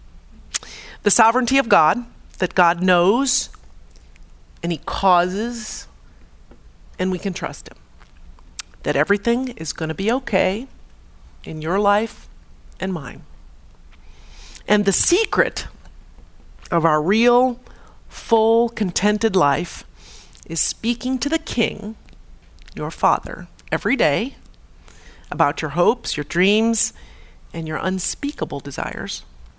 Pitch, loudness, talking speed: 185 Hz, -19 LUFS, 110 wpm